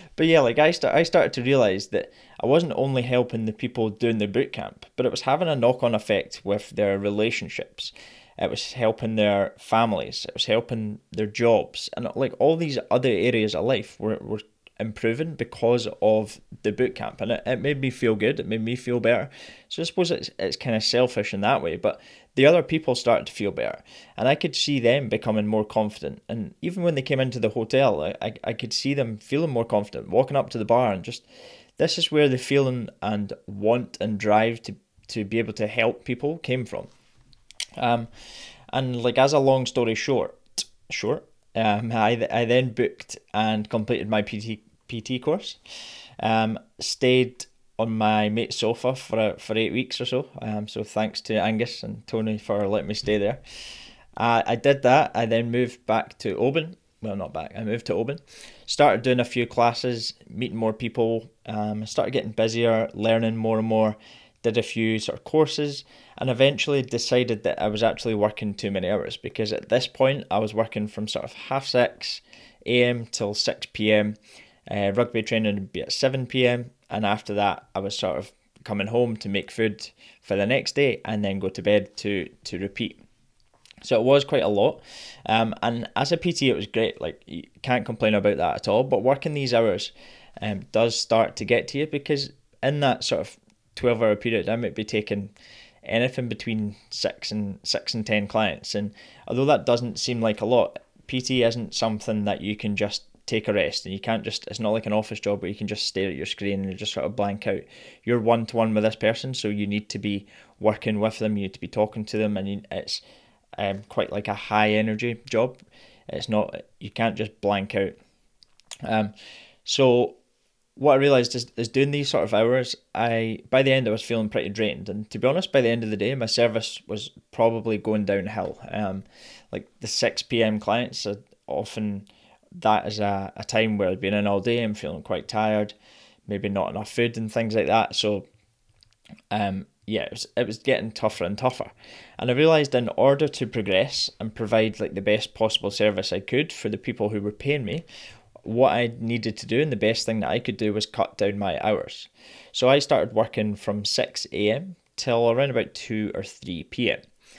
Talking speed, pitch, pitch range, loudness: 210 wpm, 110 Hz, 105-125 Hz, -24 LUFS